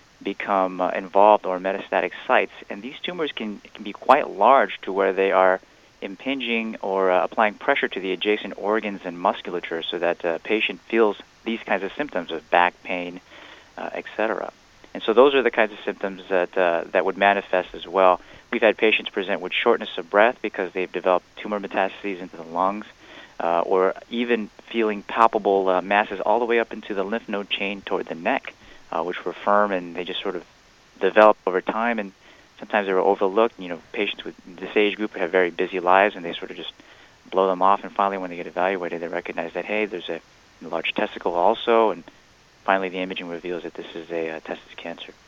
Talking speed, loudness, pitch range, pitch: 210 wpm, -22 LUFS, 95-105 Hz, 95 Hz